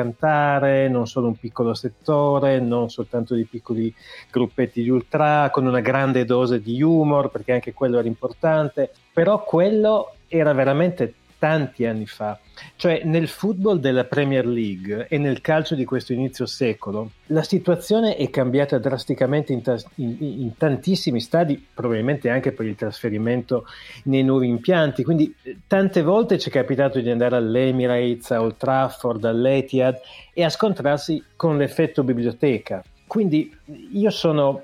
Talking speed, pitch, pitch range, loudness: 150 wpm, 135 Hz, 120-155 Hz, -21 LUFS